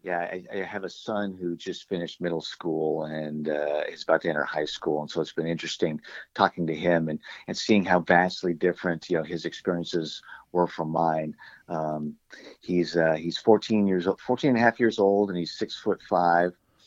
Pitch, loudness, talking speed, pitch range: 85 Hz, -27 LUFS, 205 wpm, 80-95 Hz